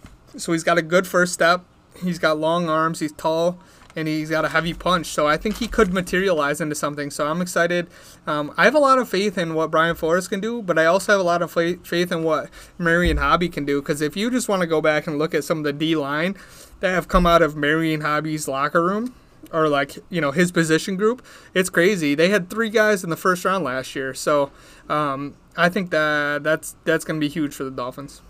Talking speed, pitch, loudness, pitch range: 245 wpm, 165 Hz, -21 LUFS, 155-180 Hz